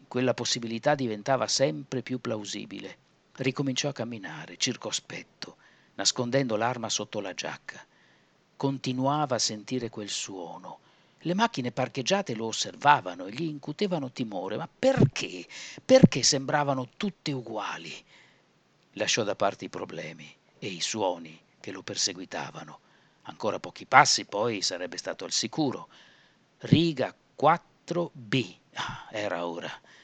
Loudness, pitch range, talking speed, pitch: -28 LUFS, 115-150 Hz, 120 wpm, 130 Hz